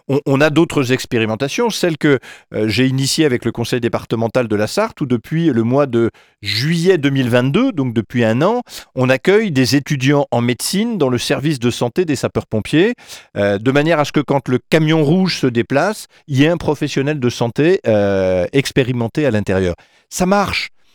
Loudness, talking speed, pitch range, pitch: -16 LUFS, 180 wpm, 115-155 Hz, 135 Hz